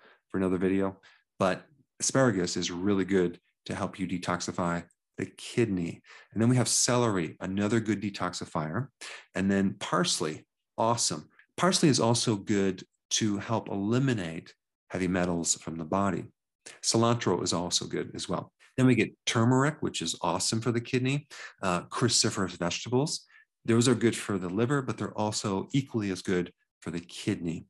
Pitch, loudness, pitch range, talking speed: 100 Hz, -29 LUFS, 90-120 Hz, 155 wpm